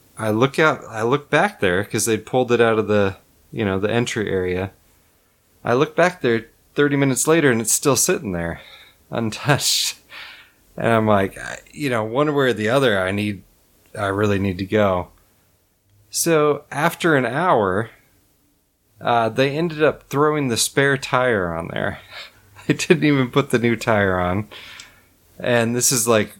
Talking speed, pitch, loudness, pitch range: 175 wpm, 115 Hz, -19 LUFS, 100-140 Hz